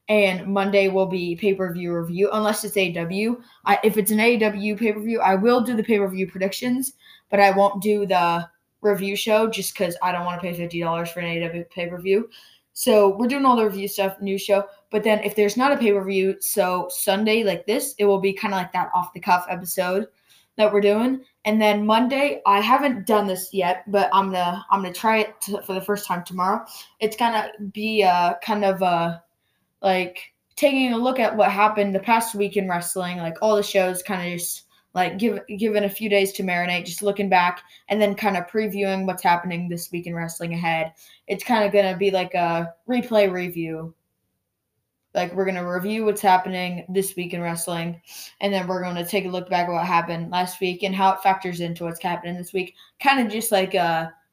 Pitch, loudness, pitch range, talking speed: 195 Hz, -22 LUFS, 180-210 Hz, 220 wpm